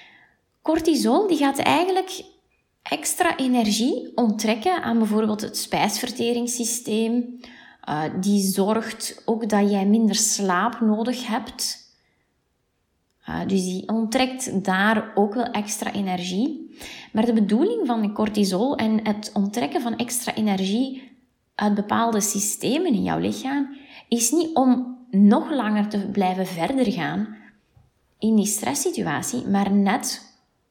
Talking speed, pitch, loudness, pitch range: 120 wpm, 230 Hz, -22 LUFS, 210-255 Hz